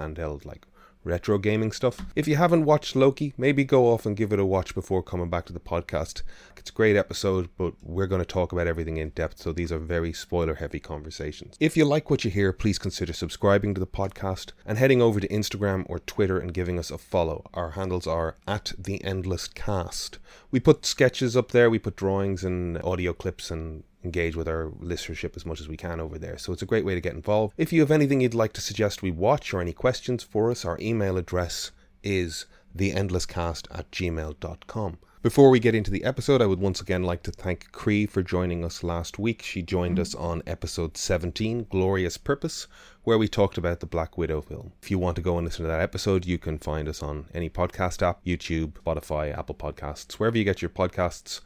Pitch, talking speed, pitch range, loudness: 95 Hz, 220 wpm, 85-105 Hz, -26 LUFS